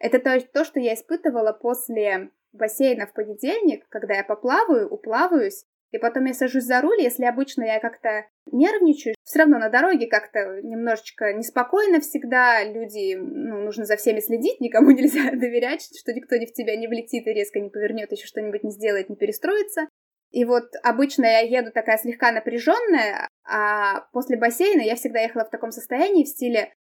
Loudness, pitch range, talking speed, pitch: -22 LUFS, 220-290 Hz, 170 wpm, 240 Hz